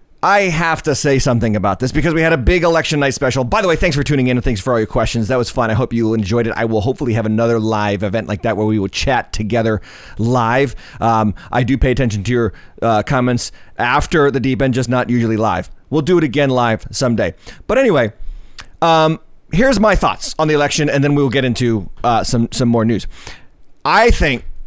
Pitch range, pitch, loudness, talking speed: 110-140 Hz, 125 Hz, -15 LUFS, 230 wpm